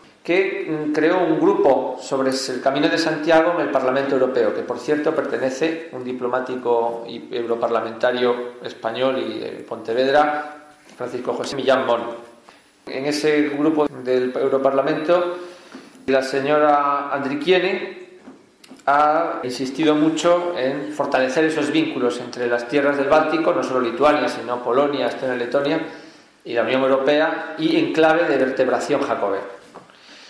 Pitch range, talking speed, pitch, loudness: 125-155 Hz, 135 wpm, 140 Hz, -20 LUFS